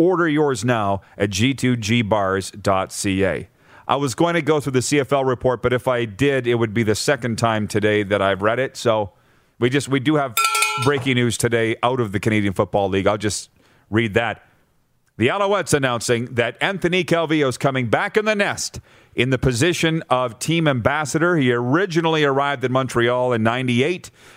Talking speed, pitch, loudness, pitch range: 180 wpm, 125 Hz, -20 LUFS, 115-145 Hz